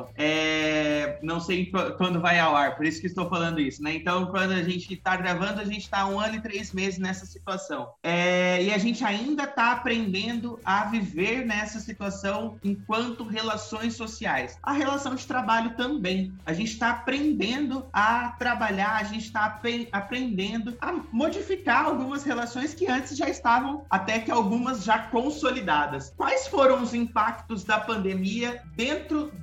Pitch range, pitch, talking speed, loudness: 190-245 Hz, 220 Hz, 160 wpm, -26 LUFS